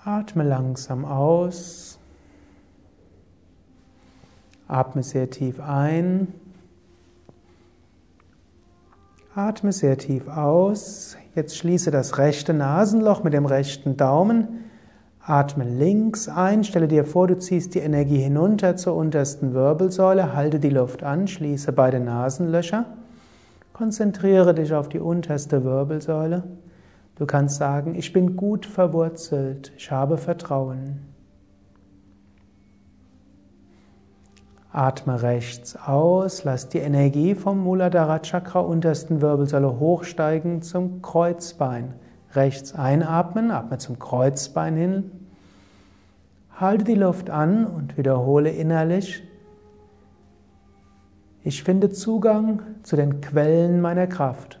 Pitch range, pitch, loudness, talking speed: 125-180 Hz, 145 Hz, -22 LUFS, 100 wpm